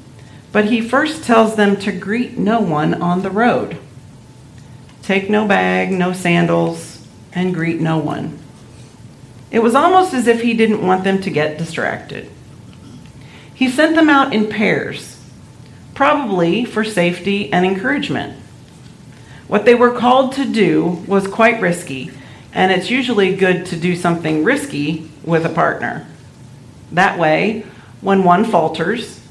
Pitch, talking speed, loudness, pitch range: 180 Hz, 140 wpm, -15 LUFS, 150-215 Hz